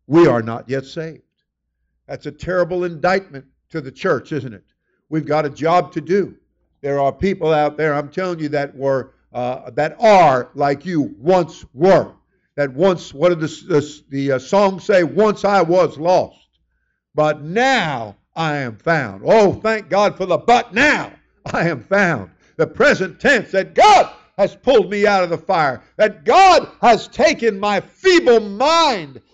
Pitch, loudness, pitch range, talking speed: 170 Hz, -16 LUFS, 145-200 Hz, 175 wpm